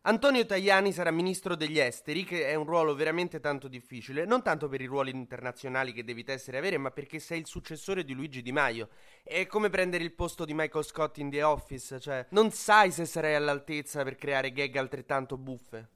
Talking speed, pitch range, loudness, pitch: 205 wpm, 135-175 Hz, -30 LUFS, 150 Hz